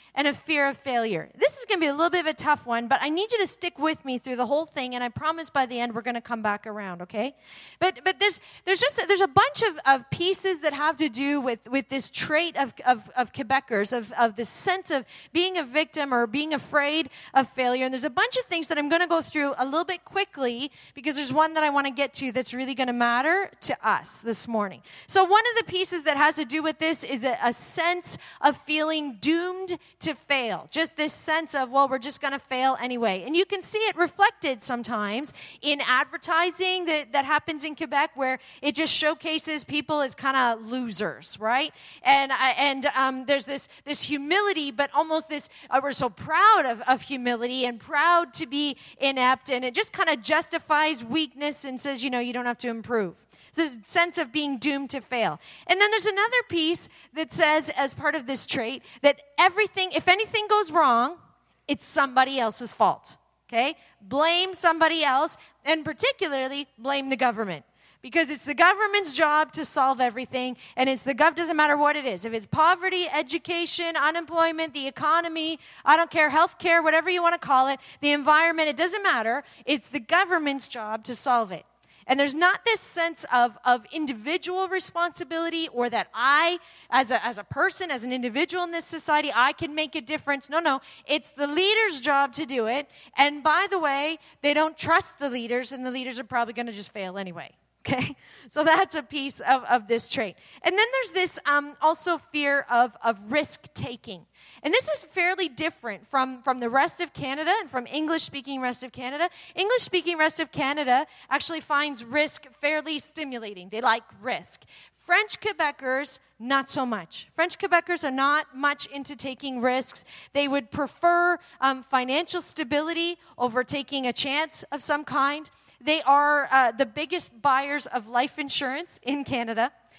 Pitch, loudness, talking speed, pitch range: 290 Hz, -24 LUFS, 200 wpm, 260-330 Hz